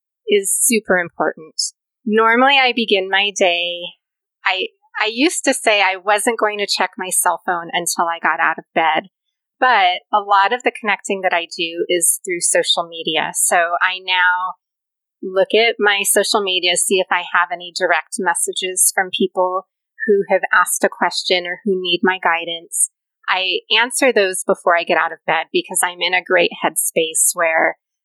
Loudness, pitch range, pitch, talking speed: -16 LUFS, 175-220 Hz, 190 Hz, 180 wpm